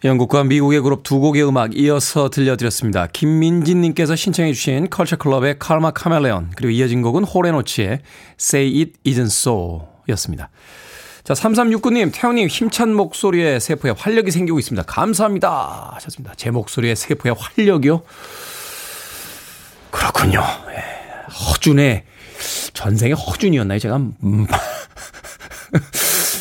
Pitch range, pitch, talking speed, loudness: 120-175 Hz, 145 Hz, 330 characters per minute, -17 LUFS